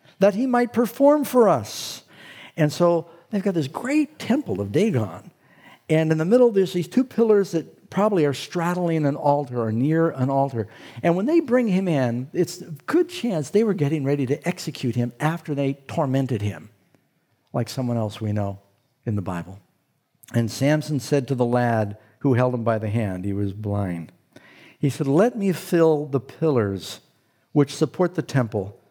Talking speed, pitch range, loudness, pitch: 185 wpm, 120-175 Hz, -23 LUFS, 145 Hz